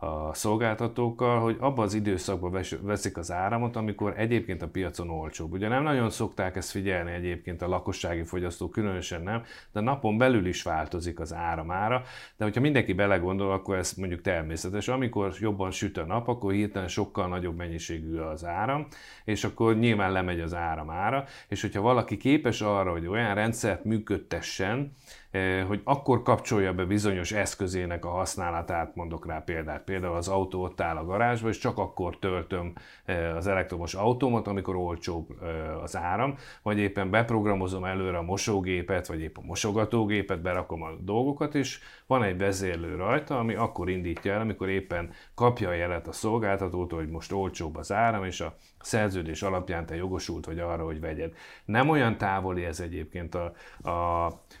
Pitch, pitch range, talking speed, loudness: 95 Hz, 85-110 Hz, 165 wpm, -29 LUFS